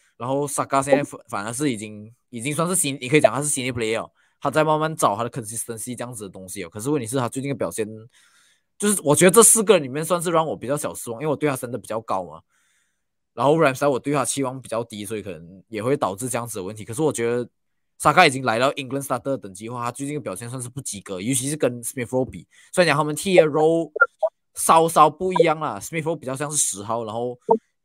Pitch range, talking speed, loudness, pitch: 115-150 Hz, 455 characters per minute, -21 LUFS, 135 Hz